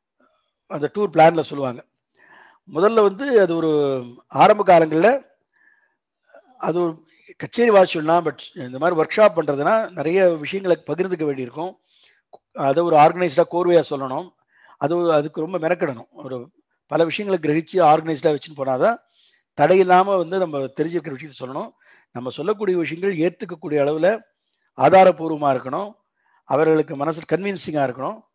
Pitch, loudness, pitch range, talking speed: 165 Hz, -19 LUFS, 150-190 Hz, 120 wpm